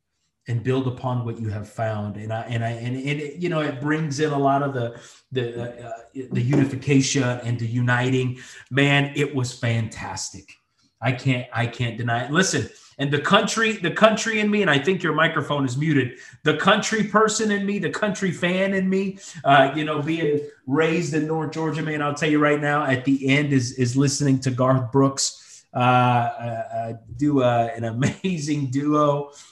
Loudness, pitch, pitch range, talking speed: -22 LUFS, 140 Hz, 125-155 Hz, 190 wpm